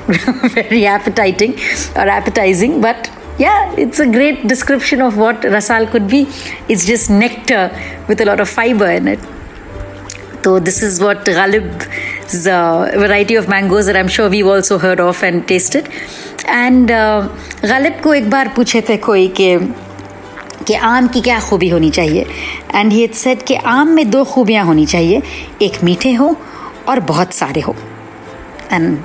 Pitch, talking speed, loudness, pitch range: 215 Hz, 130 wpm, -12 LUFS, 185-245 Hz